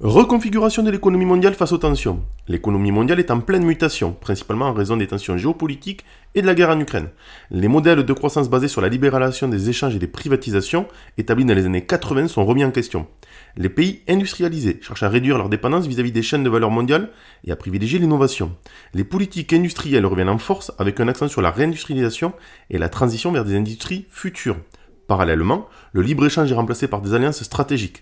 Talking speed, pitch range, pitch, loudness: 200 wpm, 105-165 Hz, 130 Hz, -19 LUFS